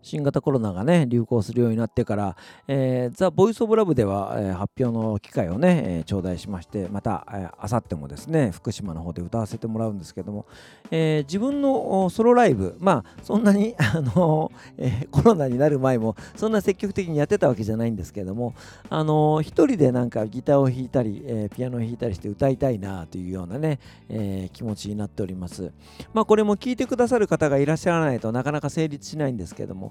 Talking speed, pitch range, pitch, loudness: 440 characters per minute, 105-155 Hz, 125 Hz, -23 LUFS